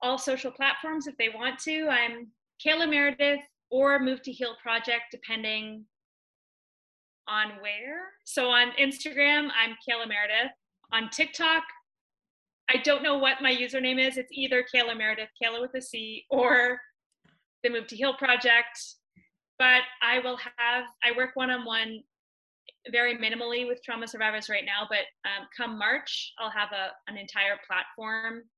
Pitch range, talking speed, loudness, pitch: 225-265 Hz, 155 wpm, -26 LUFS, 245 Hz